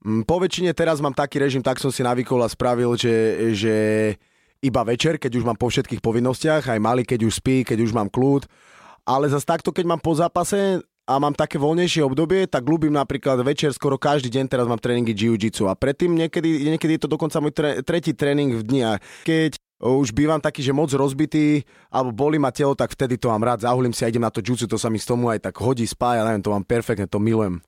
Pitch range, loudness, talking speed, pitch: 115-150 Hz, -21 LUFS, 230 wpm, 130 Hz